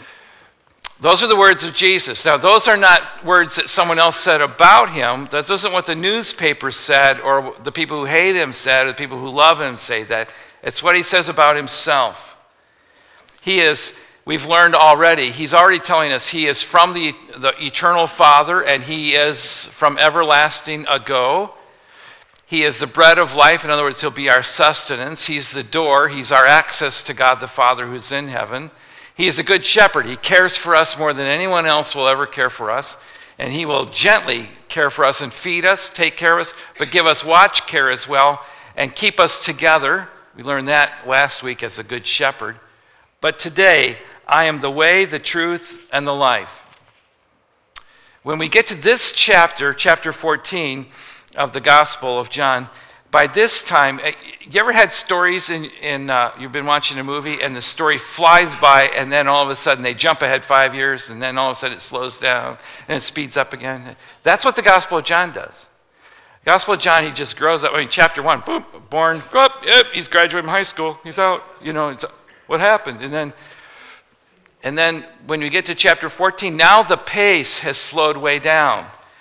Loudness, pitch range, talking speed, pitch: -14 LUFS, 140-170 Hz, 200 wpm, 155 Hz